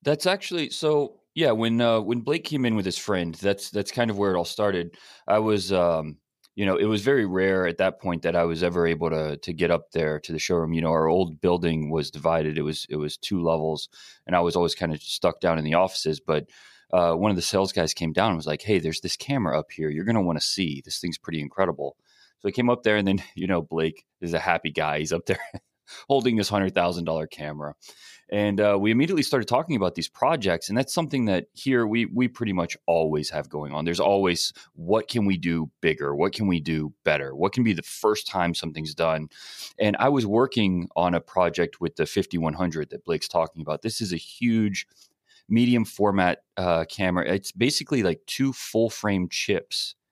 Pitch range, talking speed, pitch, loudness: 80-105 Hz, 230 wpm, 90 Hz, -25 LUFS